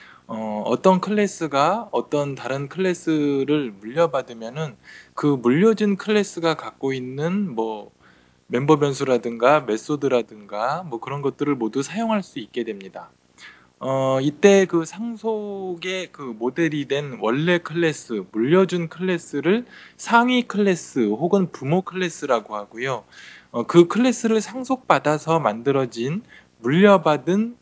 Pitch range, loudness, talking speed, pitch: 125-190 Hz, -21 LUFS, 270 characters per minute, 155 Hz